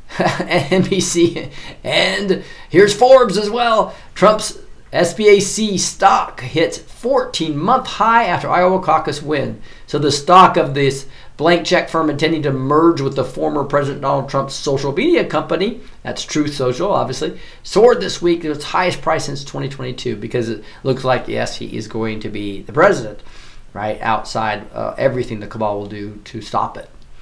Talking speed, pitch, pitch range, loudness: 160 wpm, 150 Hz, 130-180 Hz, -16 LUFS